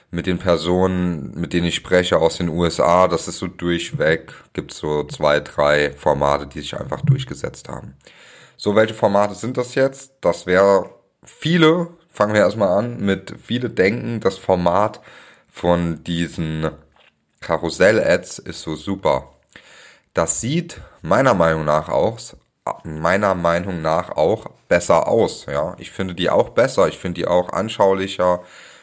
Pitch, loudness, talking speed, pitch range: 90 Hz, -19 LUFS, 150 wpm, 85-105 Hz